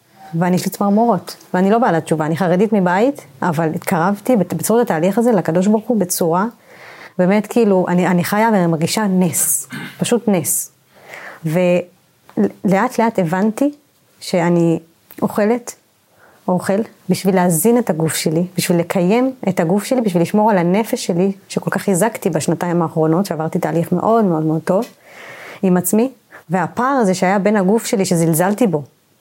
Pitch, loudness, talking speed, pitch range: 185 Hz, -16 LUFS, 150 wpm, 175-215 Hz